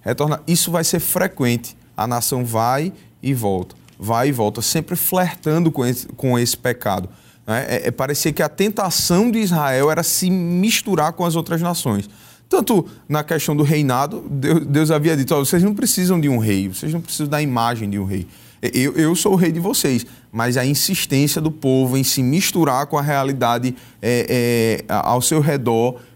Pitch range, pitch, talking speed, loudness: 120-170 Hz, 145 Hz, 190 wpm, -18 LUFS